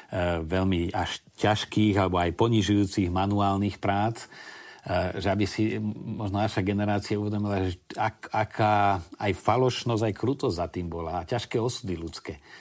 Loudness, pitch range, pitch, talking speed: -27 LUFS, 95-110 Hz, 100 Hz, 140 wpm